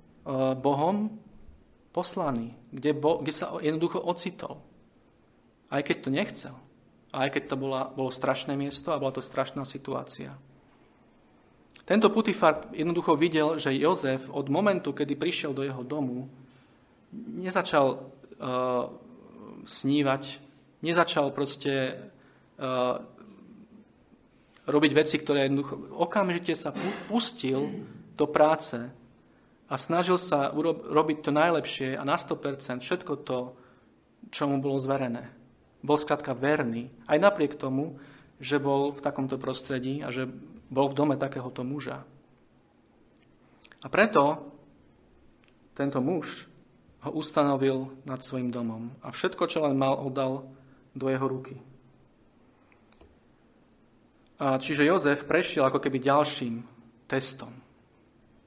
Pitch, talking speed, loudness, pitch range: 140 Hz, 115 wpm, -28 LUFS, 130-155 Hz